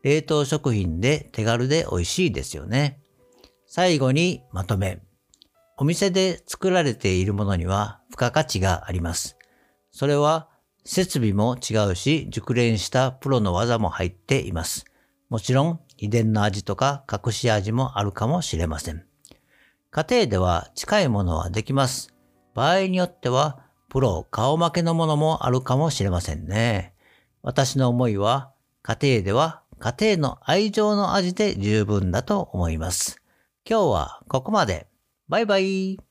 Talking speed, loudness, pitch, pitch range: 275 characters per minute, -23 LUFS, 125 Hz, 100-155 Hz